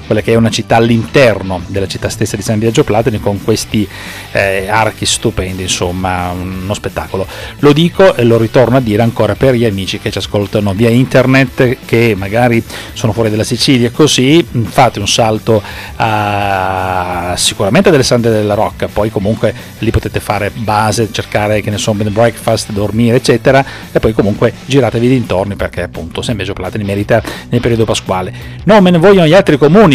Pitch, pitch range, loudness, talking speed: 110 Hz, 100-120 Hz, -11 LUFS, 175 wpm